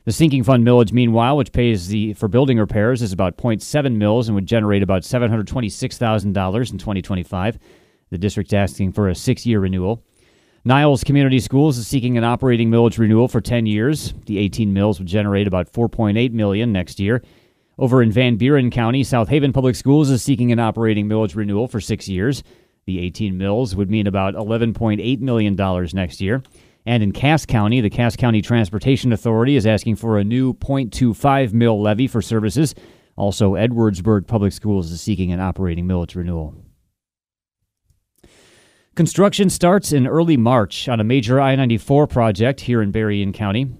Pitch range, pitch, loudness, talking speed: 100-125 Hz, 115 Hz, -18 LUFS, 170 wpm